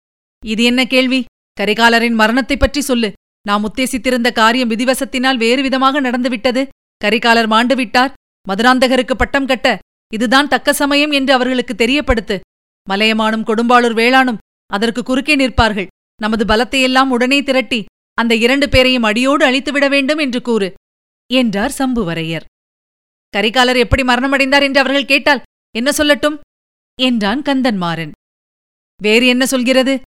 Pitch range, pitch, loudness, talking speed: 230-270 Hz, 255 Hz, -13 LUFS, 115 wpm